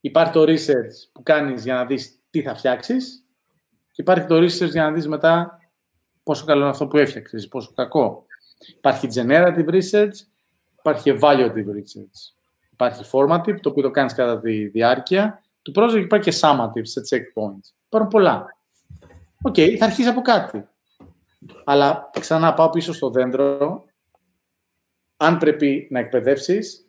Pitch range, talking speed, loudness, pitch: 125-170 Hz, 150 wpm, -19 LUFS, 145 Hz